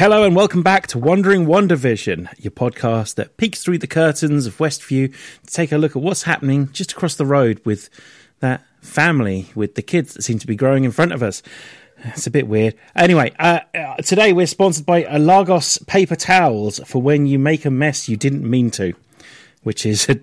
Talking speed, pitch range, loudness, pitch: 200 wpm, 125-175 Hz, -17 LUFS, 150 Hz